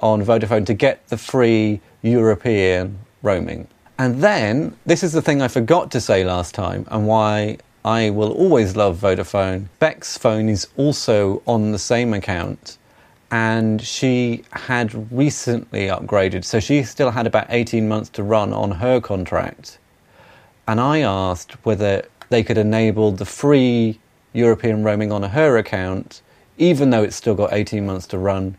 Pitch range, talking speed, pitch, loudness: 105-120 Hz, 155 wpm, 110 Hz, -18 LUFS